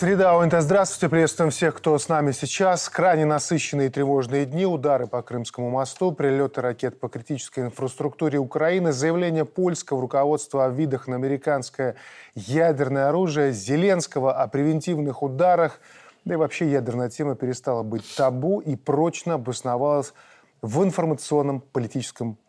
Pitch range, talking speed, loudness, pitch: 130-165 Hz, 135 wpm, -23 LUFS, 145 Hz